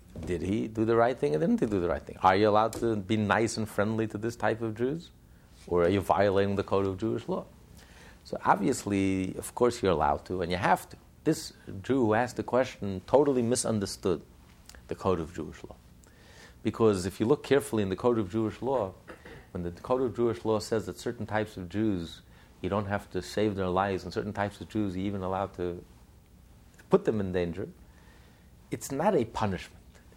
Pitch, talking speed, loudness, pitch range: 100 Hz, 210 wpm, -29 LUFS, 90-110 Hz